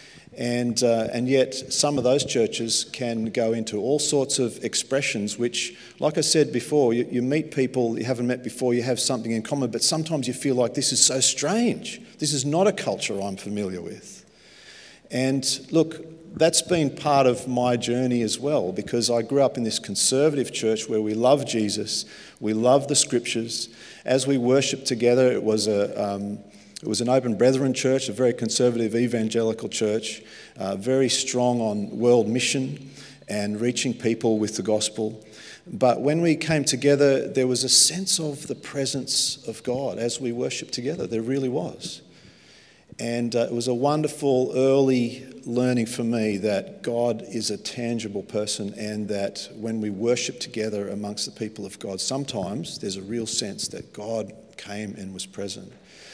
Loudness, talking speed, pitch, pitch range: -23 LUFS, 175 wpm, 120 Hz, 110-135 Hz